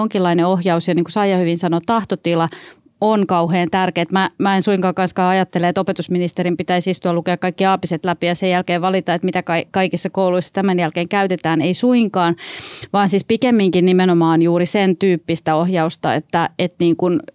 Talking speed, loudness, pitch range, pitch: 175 wpm, -17 LUFS, 170-190 Hz, 180 Hz